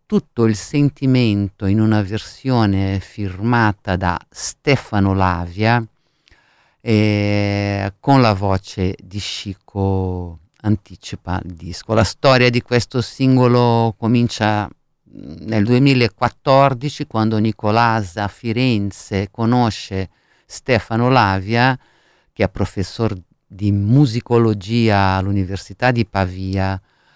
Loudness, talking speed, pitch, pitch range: -17 LUFS, 90 wpm, 105 Hz, 95-120 Hz